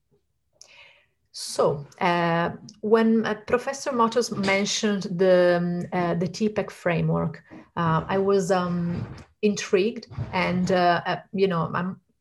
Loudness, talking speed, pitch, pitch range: -24 LUFS, 120 wpm, 190 Hz, 175-210 Hz